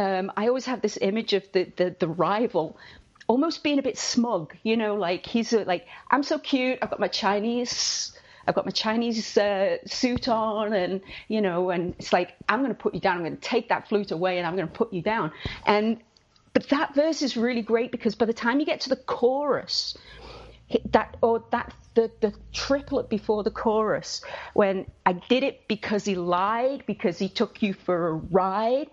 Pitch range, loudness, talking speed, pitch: 190-245 Hz, -26 LUFS, 210 wpm, 220 Hz